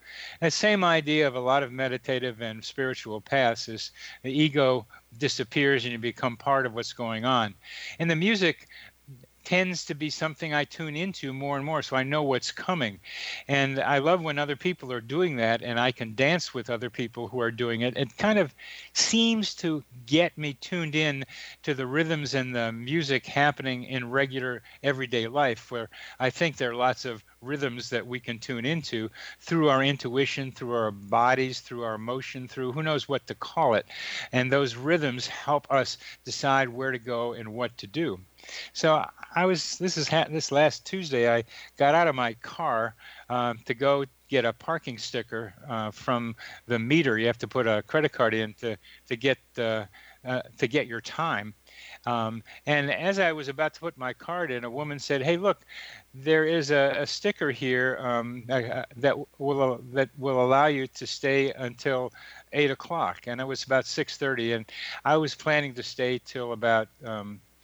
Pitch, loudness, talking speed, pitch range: 130 Hz, -27 LUFS, 190 wpm, 120-150 Hz